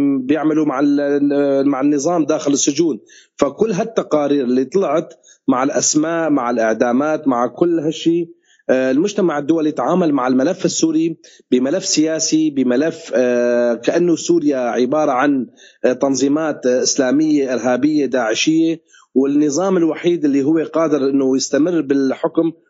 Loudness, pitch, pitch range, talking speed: -16 LUFS, 150 Hz, 135-165 Hz, 110 wpm